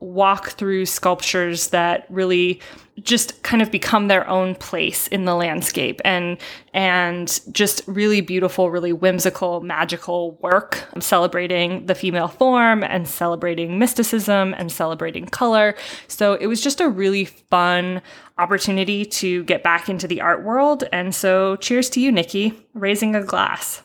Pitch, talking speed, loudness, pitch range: 185 Hz, 150 wpm, -19 LUFS, 175-210 Hz